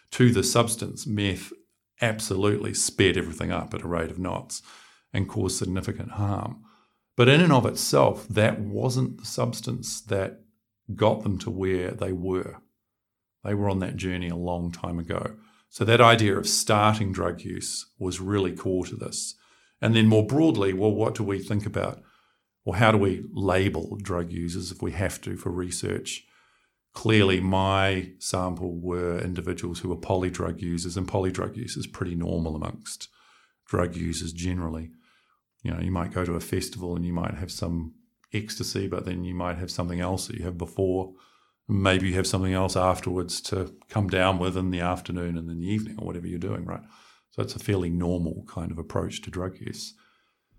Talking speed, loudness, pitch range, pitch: 185 wpm, -26 LUFS, 90-110 Hz, 95 Hz